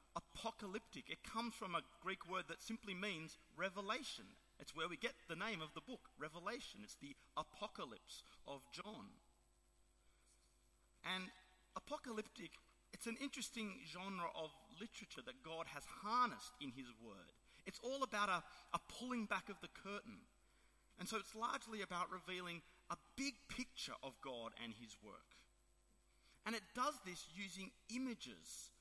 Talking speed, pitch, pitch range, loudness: 150 wpm, 195 Hz, 165-225 Hz, -49 LUFS